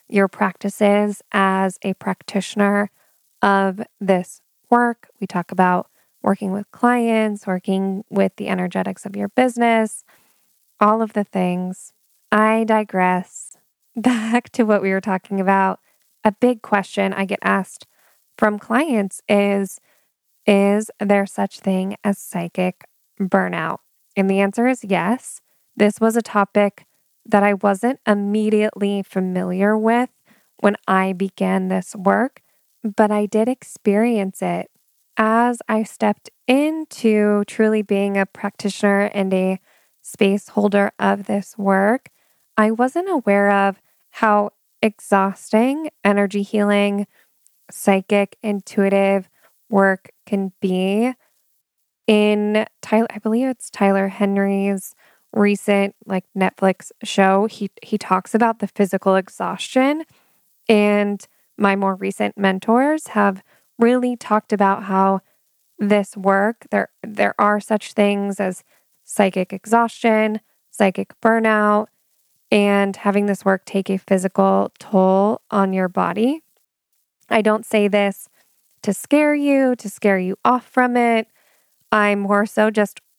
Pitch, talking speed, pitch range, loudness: 205 Hz, 125 wpm, 195-220 Hz, -19 LUFS